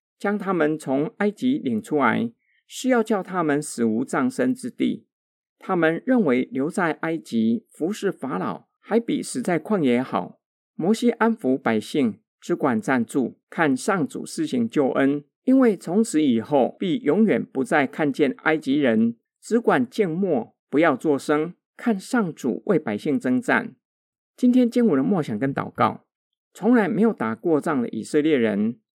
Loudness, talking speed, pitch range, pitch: -23 LUFS, 230 characters per minute, 155-245 Hz, 220 Hz